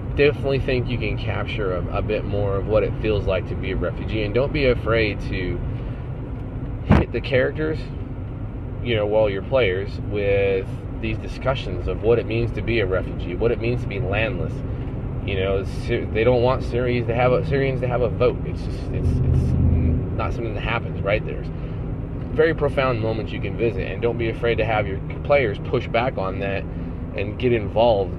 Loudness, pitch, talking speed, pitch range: -23 LUFS, 115 Hz, 200 wpm, 100-125 Hz